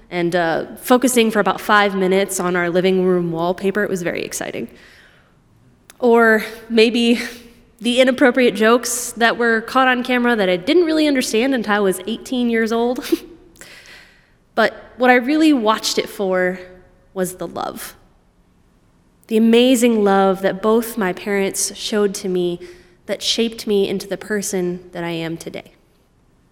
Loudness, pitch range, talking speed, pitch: -17 LUFS, 185-240 Hz, 150 wpm, 215 Hz